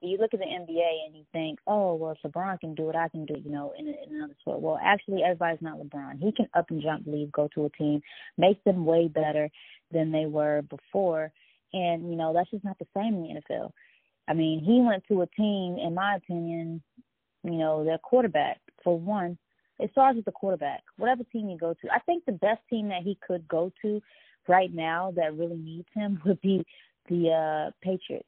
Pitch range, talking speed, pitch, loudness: 160-200 Hz, 225 wpm, 175 Hz, -28 LUFS